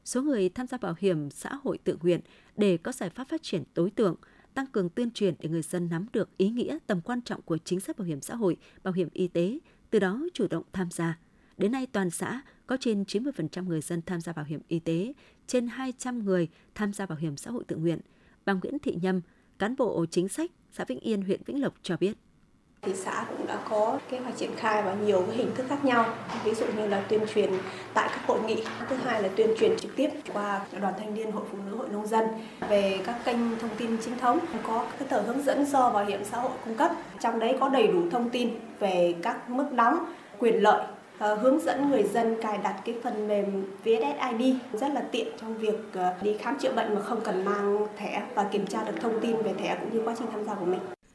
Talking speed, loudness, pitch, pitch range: 240 wpm, -29 LUFS, 215 Hz, 190-245 Hz